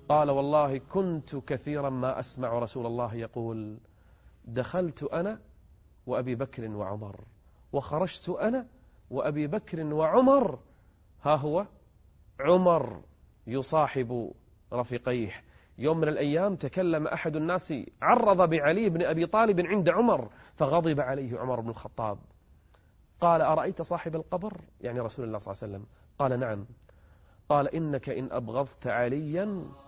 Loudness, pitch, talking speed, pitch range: -29 LUFS, 135 Hz, 120 wpm, 110-160 Hz